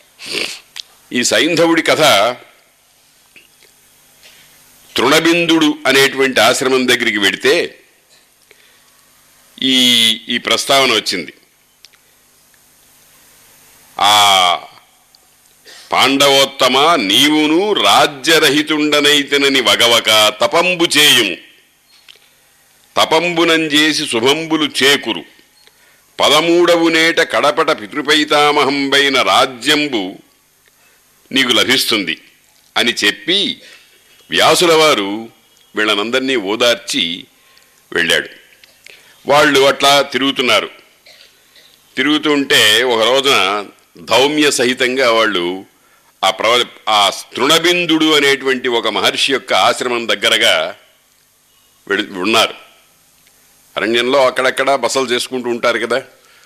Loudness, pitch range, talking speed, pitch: -12 LUFS, 130-155 Hz, 65 wpm, 140 Hz